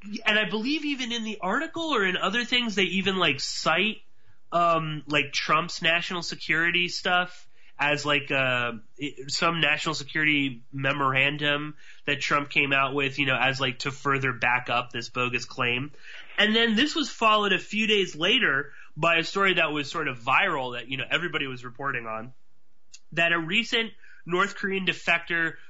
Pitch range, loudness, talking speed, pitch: 135-190 Hz, -25 LUFS, 175 wpm, 160 Hz